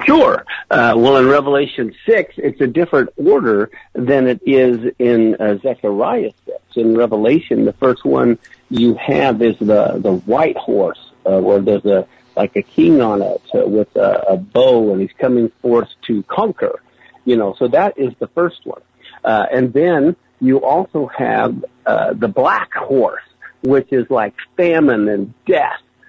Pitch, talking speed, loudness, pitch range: 130 Hz, 170 wpm, -15 LUFS, 120-180 Hz